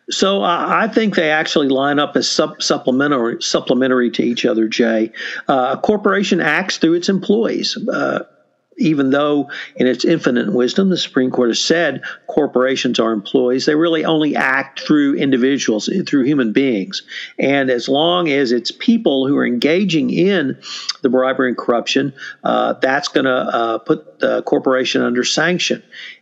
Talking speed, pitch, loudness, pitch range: 160 wpm, 140 Hz, -16 LUFS, 125-165 Hz